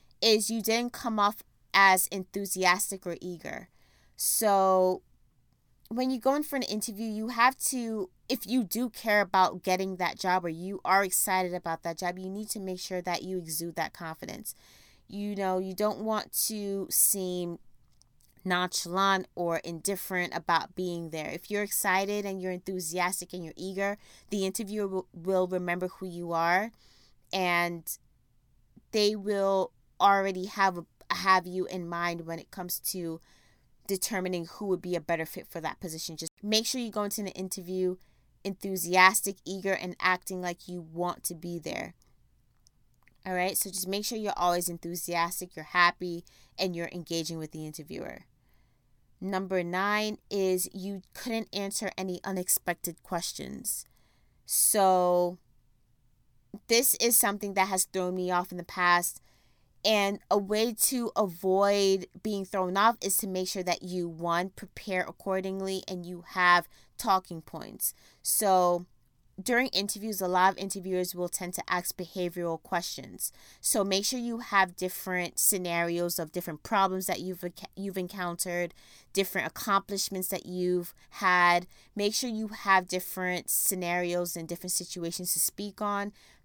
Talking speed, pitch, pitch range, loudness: 150 wpm, 185 Hz, 175-195 Hz, -29 LUFS